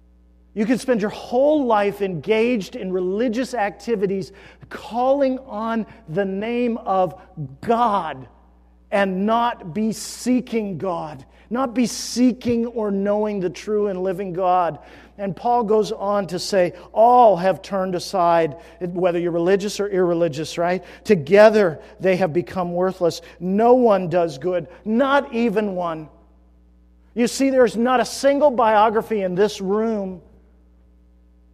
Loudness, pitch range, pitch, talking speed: -20 LUFS, 175-230 Hz, 200 Hz, 130 wpm